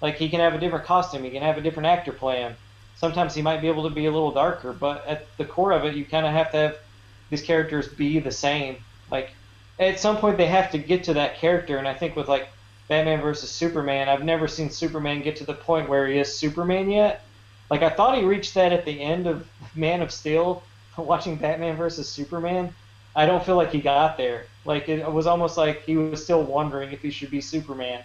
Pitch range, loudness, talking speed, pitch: 140-165 Hz, -24 LUFS, 235 wpm, 155 Hz